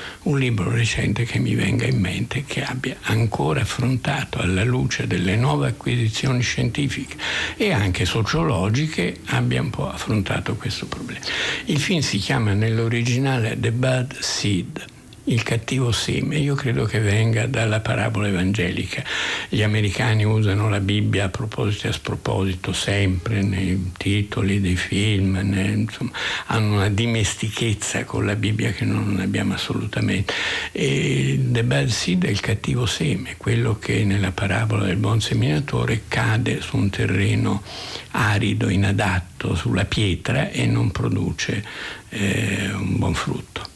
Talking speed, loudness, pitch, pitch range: 140 wpm, -22 LUFS, 110 Hz, 100-120 Hz